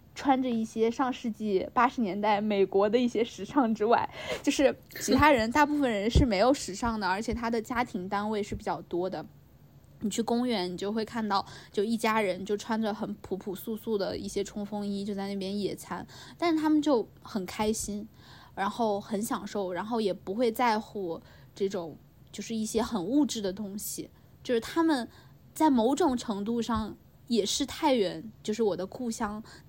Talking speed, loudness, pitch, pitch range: 270 characters per minute, -29 LUFS, 220 Hz, 200-240 Hz